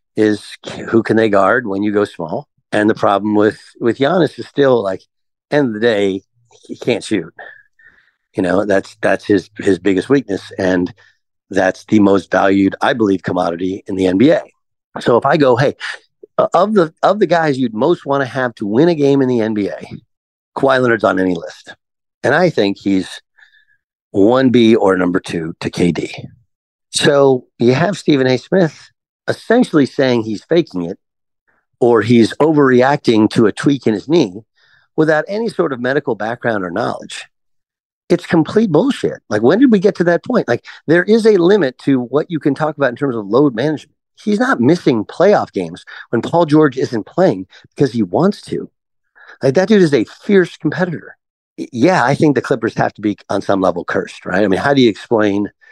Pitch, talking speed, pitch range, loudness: 135 Hz, 190 wpm, 105-170 Hz, -15 LUFS